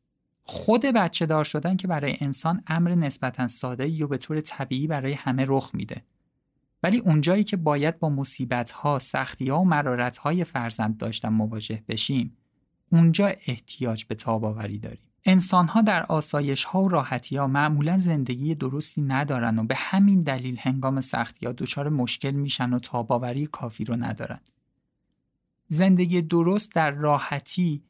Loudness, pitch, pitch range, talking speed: -24 LUFS, 140 Hz, 125-165 Hz, 155 wpm